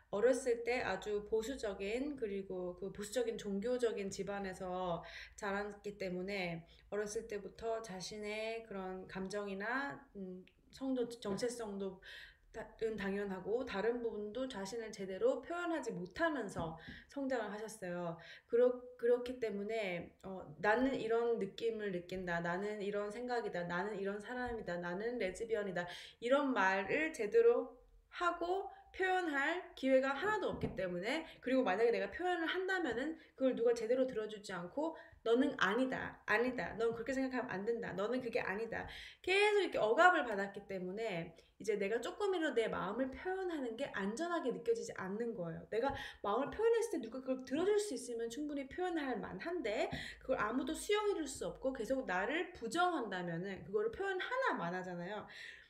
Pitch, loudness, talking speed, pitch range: 230 Hz, -38 LUFS, 335 characters per minute, 200-280 Hz